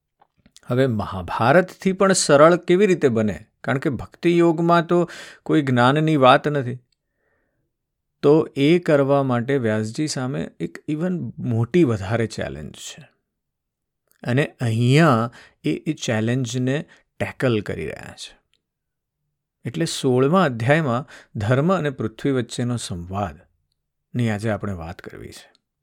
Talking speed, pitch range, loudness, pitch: 115 wpm, 115-155 Hz, -20 LUFS, 135 Hz